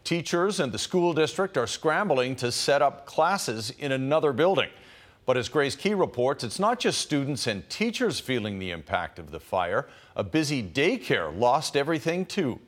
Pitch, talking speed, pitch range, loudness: 140 Hz, 175 wpm, 120-170 Hz, -26 LUFS